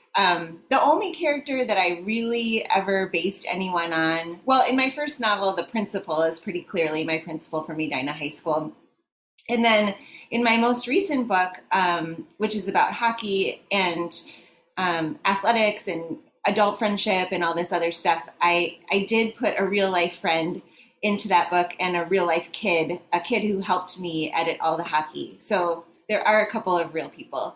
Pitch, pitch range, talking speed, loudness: 185 Hz, 170-215 Hz, 180 wpm, -23 LUFS